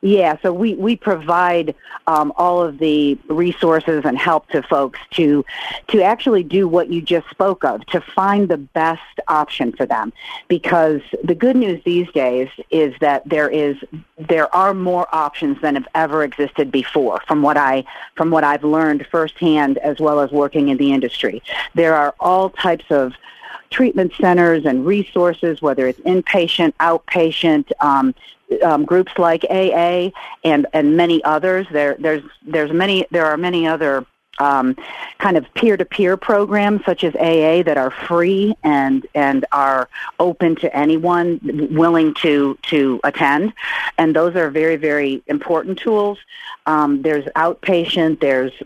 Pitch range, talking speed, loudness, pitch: 145-180 Hz, 155 wpm, -16 LUFS, 160 Hz